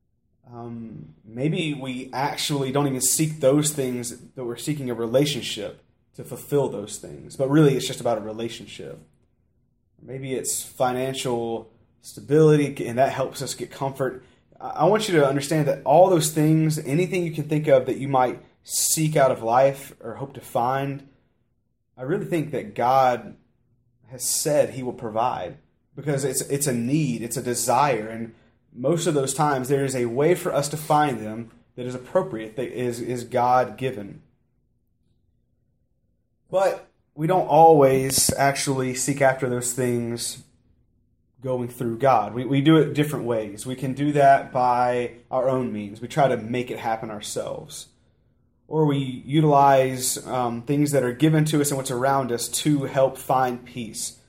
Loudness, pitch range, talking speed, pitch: -22 LUFS, 120-145 Hz, 165 wpm, 130 Hz